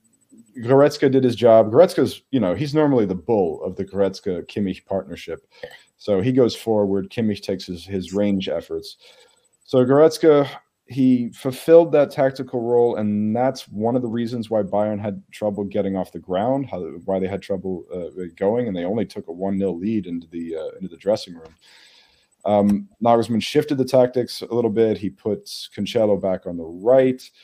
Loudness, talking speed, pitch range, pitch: -20 LUFS, 180 wpm, 95-130 Hz, 110 Hz